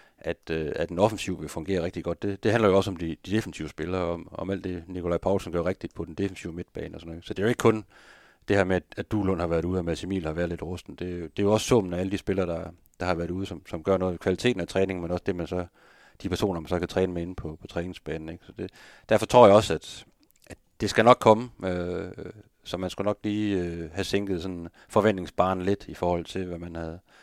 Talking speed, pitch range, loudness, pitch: 275 wpm, 85-100 Hz, -27 LUFS, 90 Hz